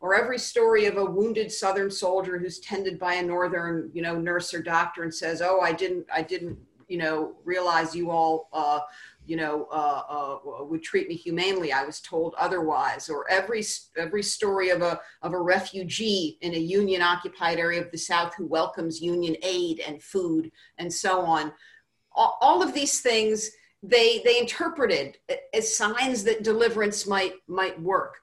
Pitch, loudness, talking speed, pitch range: 185 Hz, -26 LUFS, 180 wpm, 170-220 Hz